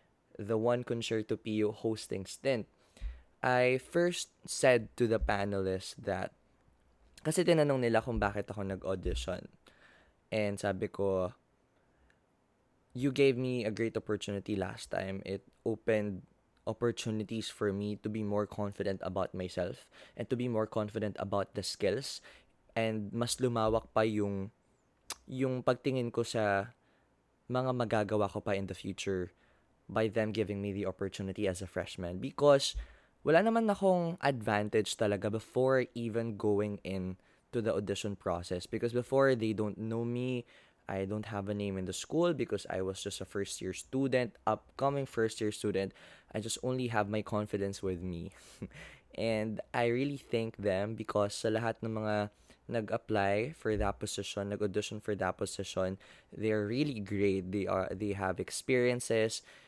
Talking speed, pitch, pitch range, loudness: 150 wpm, 105 Hz, 100-120 Hz, -34 LUFS